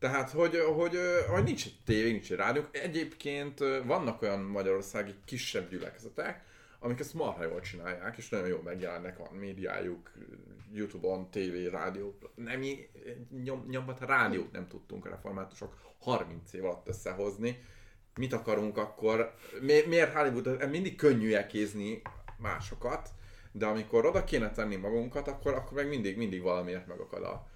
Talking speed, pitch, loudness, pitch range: 145 wpm, 115 Hz, -33 LUFS, 100-140 Hz